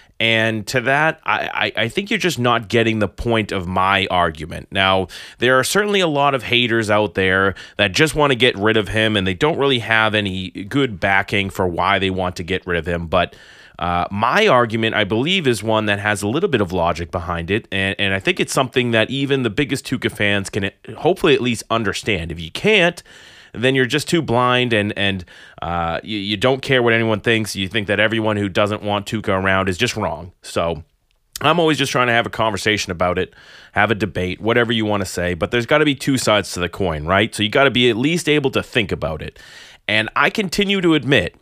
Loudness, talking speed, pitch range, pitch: -18 LUFS, 235 wpm, 95-125 Hz, 110 Hz